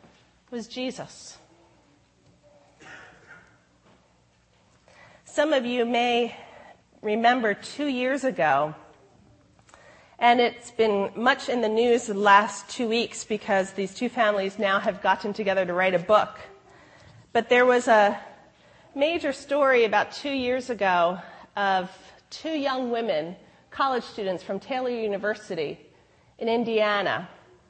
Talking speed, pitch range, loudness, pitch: 115 wpm, 195-245 Hz, -24 LUFS, 220 Hz